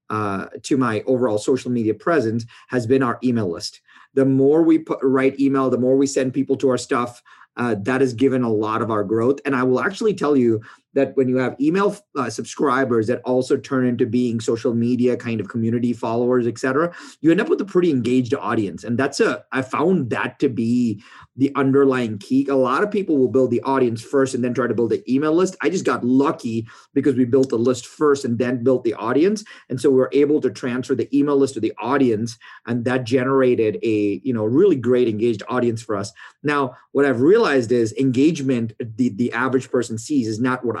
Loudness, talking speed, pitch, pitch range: -20 LUFS, 220 wpm, 130 Hz, 120-135 Hz